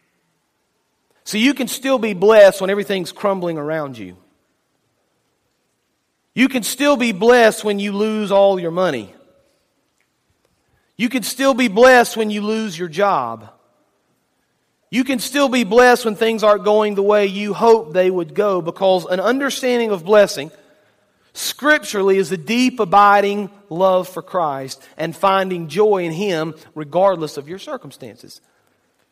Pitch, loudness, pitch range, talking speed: 205 Hz, -16 LUFS, 180-225 Hz, 145 wpm